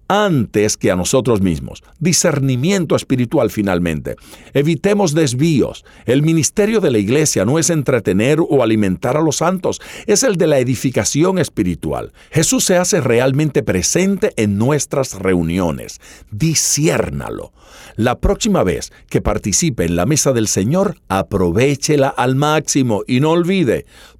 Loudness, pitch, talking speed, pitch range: -15 LUFS, 140 Hz, 135 wpm, 105-165 Hz